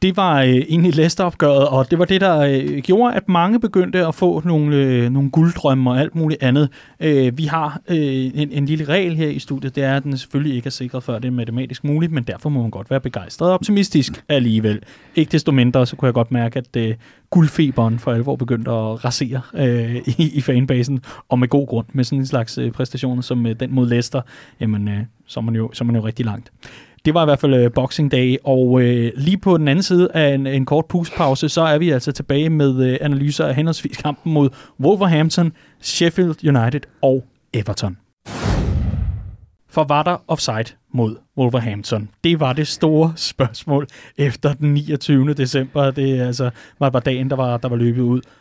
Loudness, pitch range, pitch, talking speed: -18 LUFS, 125-155 Hz, 135 Hz, 205 wpm